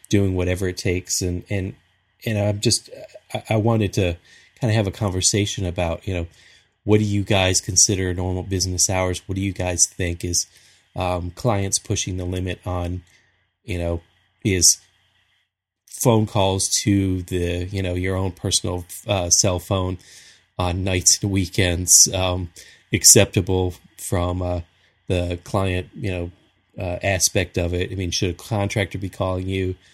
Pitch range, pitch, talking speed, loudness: 90-100 Hz, 95 Hz, 160 wpm, -20 LUFS